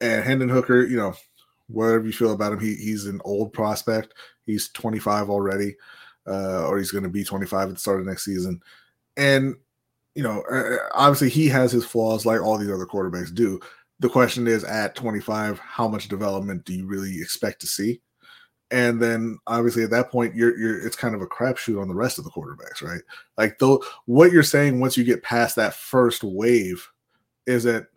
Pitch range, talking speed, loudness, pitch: 100-120 Hz, 195 wpm, -22 LUFS, 115 Hz